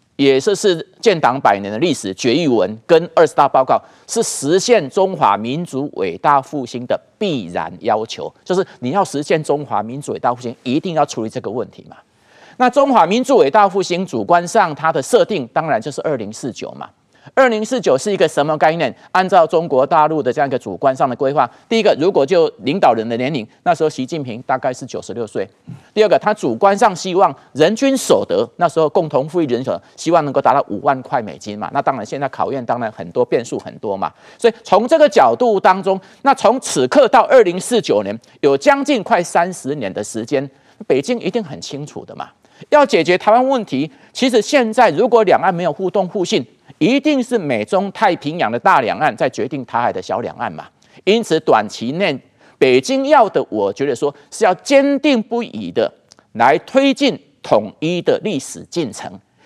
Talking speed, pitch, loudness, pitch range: 300 characters per minute, 195 Hz, -16 LUFS, 155-250 Hz